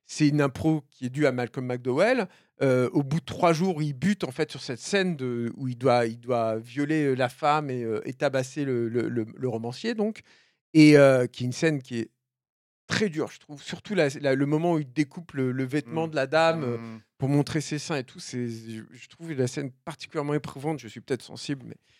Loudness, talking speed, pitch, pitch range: -26 LUFS, 235 wpm, 140 Hz, 125-155 Hz